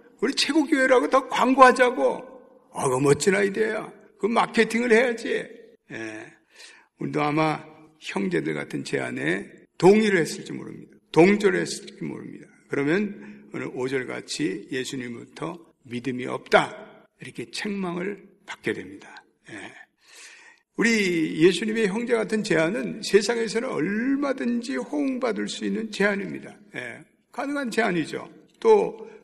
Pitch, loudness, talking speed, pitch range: 220 Hz, -23 LUFS, 280 characters per minute, 175-255 Hz